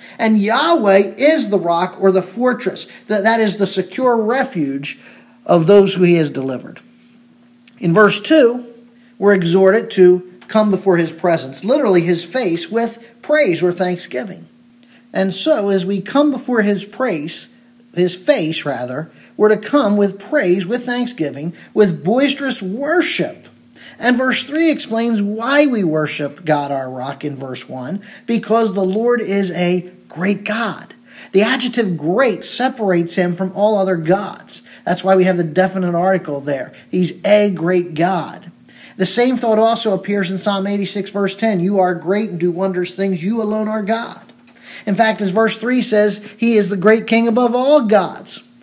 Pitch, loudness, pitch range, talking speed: 200 Hz, -16 LUFS, 180-235 Hz, 165 wpm